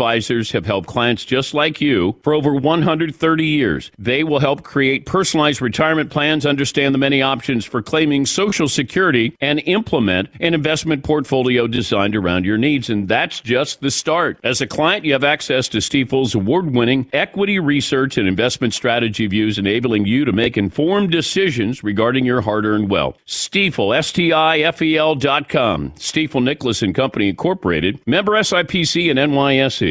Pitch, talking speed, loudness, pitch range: 140 Hz, 170 wpm, -17 LUFS, 120-155 Hz